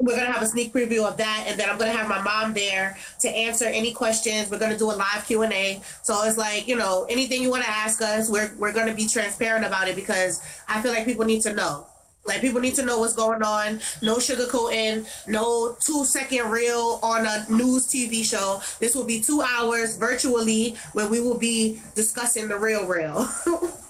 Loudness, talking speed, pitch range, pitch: -23 LUFS, 225 wpm, 215-240 Hz, 225 Hz